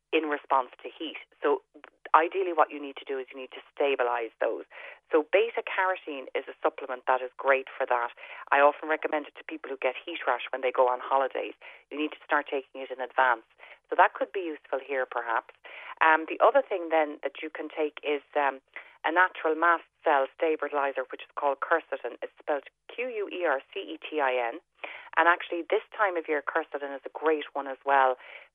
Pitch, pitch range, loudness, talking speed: 150 Hz, 135-175 Hz, -28 LUFS, 215 wpm